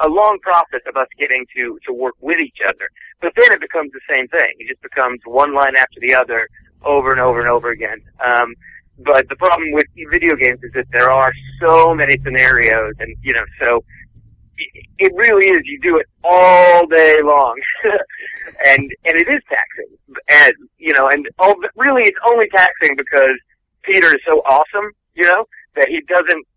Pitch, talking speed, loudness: 160 Hz, 195 wpm, -13 LUFS